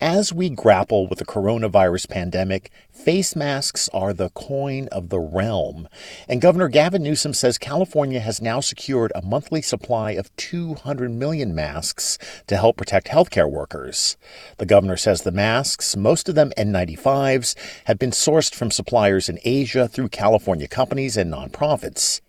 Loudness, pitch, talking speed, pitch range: -20 LUFS, 125 Hz, 155 wpm, 100-145 Hz